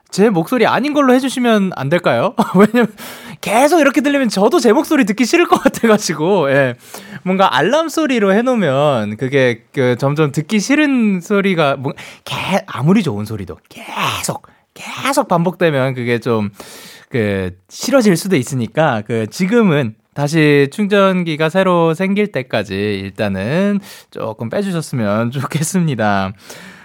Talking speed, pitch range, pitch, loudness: 295 characters per minute, 130-220 Hz, 180 Hz, -15 LUFS